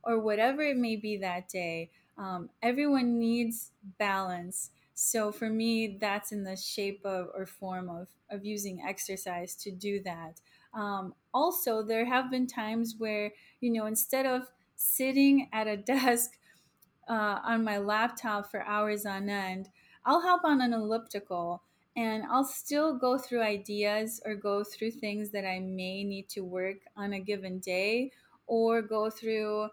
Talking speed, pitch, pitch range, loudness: 160 wpm, 210 Hz, 195-230 Hz, -31 LUFS